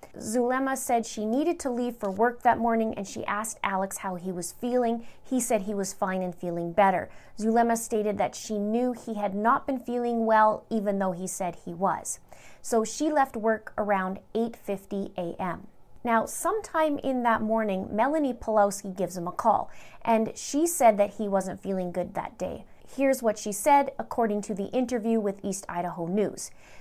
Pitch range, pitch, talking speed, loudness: 195-240 Hz, 220 Hz, 185 wpm, -27 LUFS